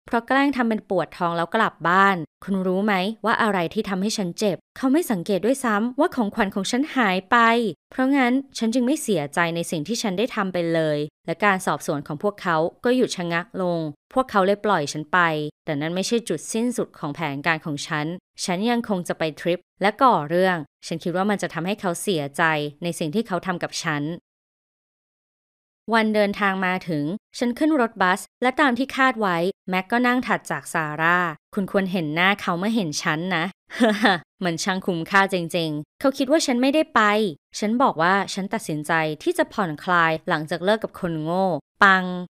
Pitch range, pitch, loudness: 170-225 Hz, 190 Hz, -22 LUFS